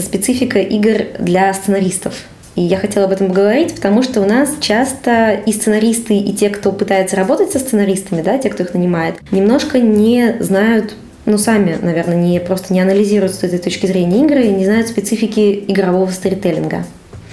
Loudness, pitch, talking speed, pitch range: -14 LUFS, 200 Hz, 175 wpm, 190-220 Hz